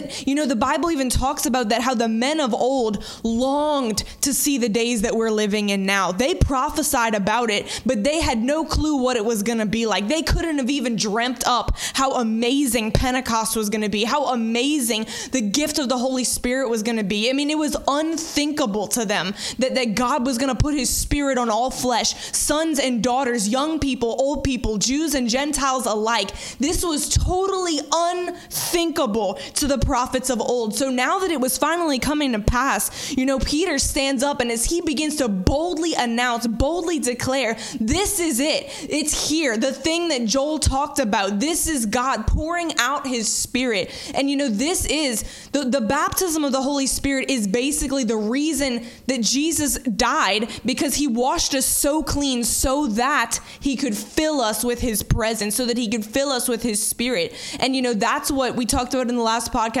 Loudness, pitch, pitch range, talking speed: -21 LUFS, 260 Hz, 235-290 Hz, 195 wpm